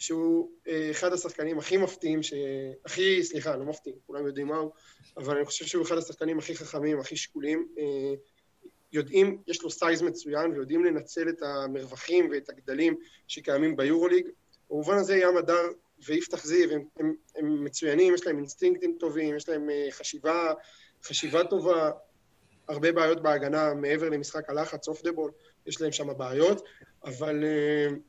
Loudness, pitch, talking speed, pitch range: -28 LUFS, 155 Hz, 150 wpm, 150-175 Hz